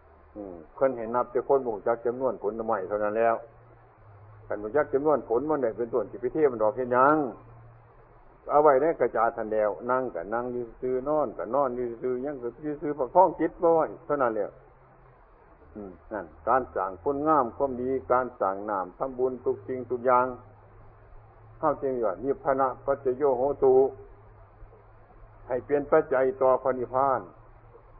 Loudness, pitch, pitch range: -27 LUFS, 125 Hz, 110-135 Hz